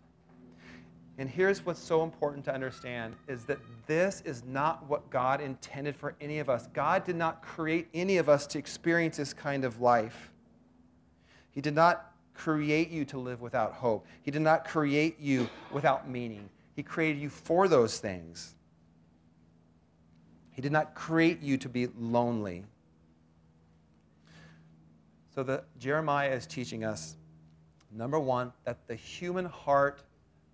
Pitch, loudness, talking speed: 130 Hz, -31 LUFS, 145 wpm